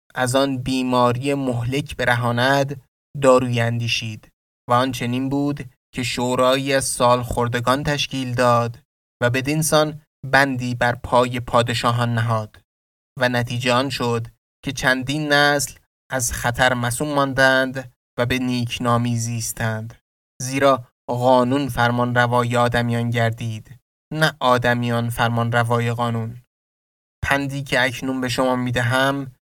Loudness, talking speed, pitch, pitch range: -20 LUFS, 115 wpm, 125 Hz, 120-135 Hz